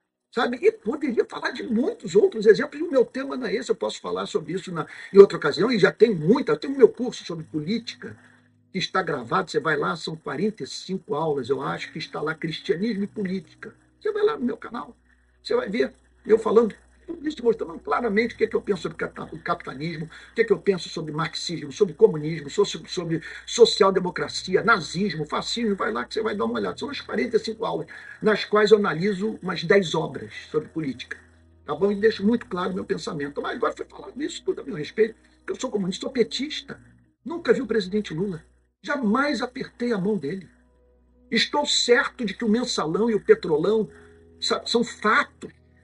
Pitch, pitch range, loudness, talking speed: 215 Hz, 170-240 Hz, -24 LUFS, 200 wpm